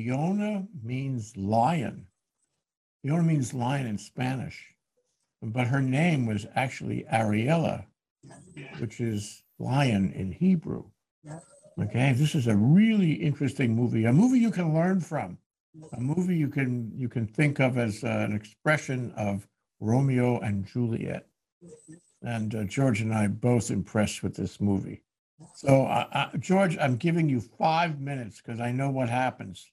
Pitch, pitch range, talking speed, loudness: 130 Hz, 115-155 Hz, 145 wpm, -27 LUFS